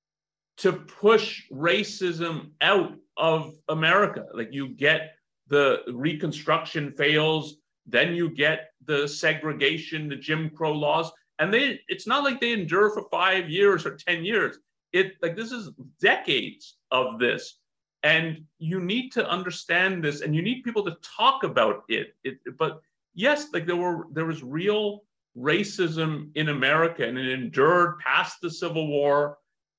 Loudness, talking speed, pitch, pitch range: -25 LUFS, 150 wpm, 165 Hz, 155-195 Hz